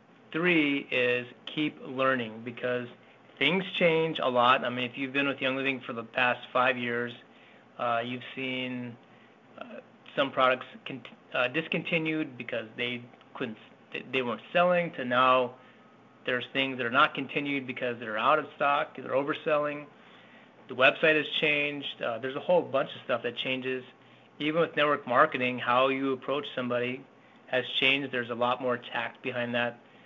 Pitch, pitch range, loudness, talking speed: 130 Hz, 125-145 Hz, -28 LUFS, 165 wpm